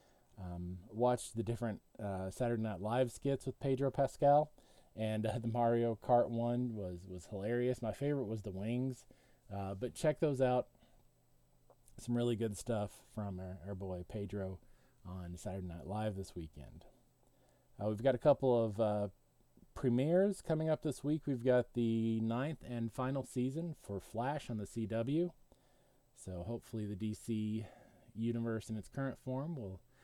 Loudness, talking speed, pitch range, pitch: -38 LUFS, 160 wpm, 105-130 Hz, 115 Hz